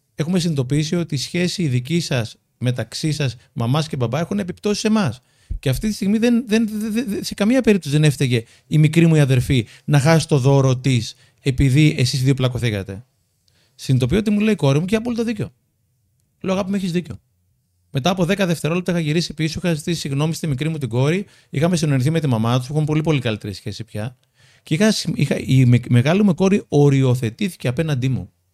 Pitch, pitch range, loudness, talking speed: 145 Hz, 125-175 Hz, -19 LUFS, 205 wpm